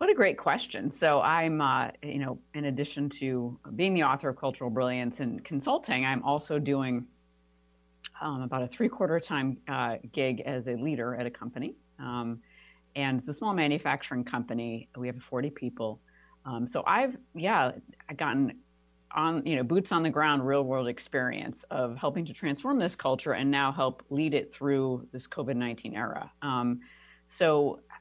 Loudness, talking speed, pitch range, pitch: -30 LUFS, 170 wpm, 120-145 Hz, 130 Hz